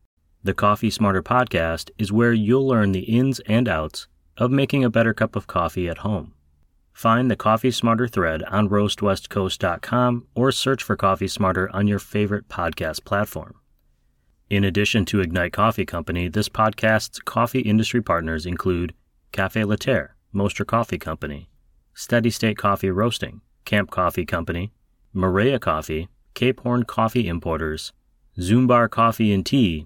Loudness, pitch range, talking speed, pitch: -22 LUFS, 85-115 Hz, 145 wpm, 100 Hz